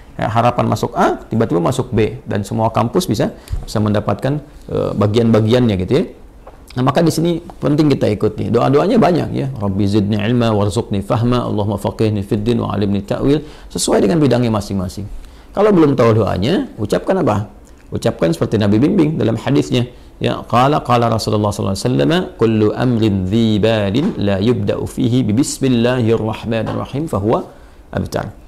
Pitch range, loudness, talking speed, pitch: 105-125 Hz, -16 LUFS, 155 wpm, 110 Hz